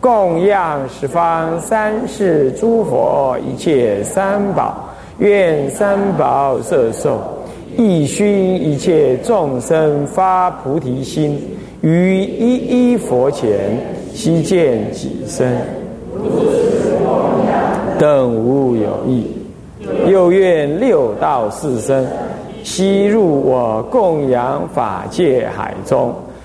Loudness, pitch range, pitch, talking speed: -15 LUFS, 150-205 Hz, 185 Hz, 125 characters per minute